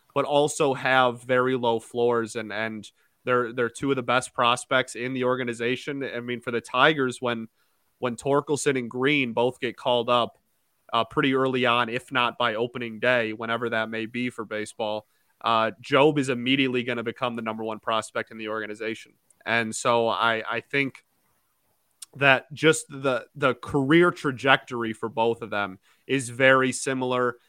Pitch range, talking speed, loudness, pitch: 115-130 Hz, 170 wpm, -25 LUFS, 120 Hz